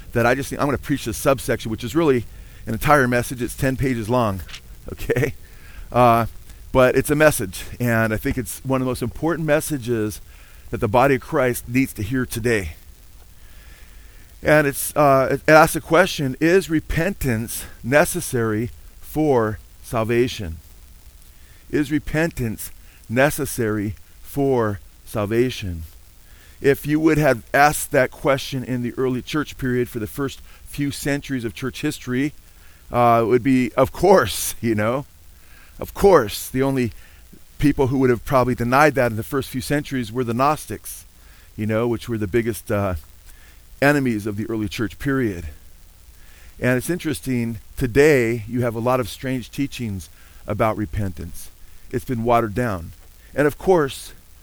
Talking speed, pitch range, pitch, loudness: 155 wpm, 90-135 Hz, 120 Hz, -20 LUFS